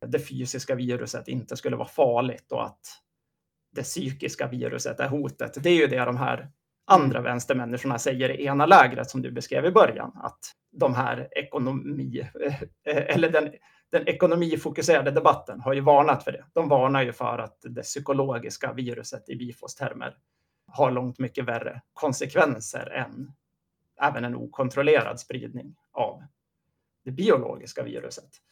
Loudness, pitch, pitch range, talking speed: -25 LUFS, 135 Hz, 125-145 Hz, 145 wpm